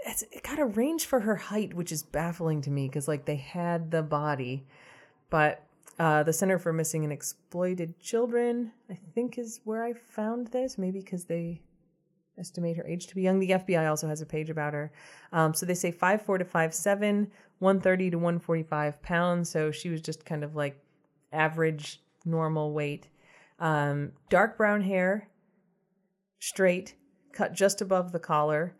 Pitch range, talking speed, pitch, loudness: 155-195 Hz, 175 wpm, 170 Hz, -29 LUFS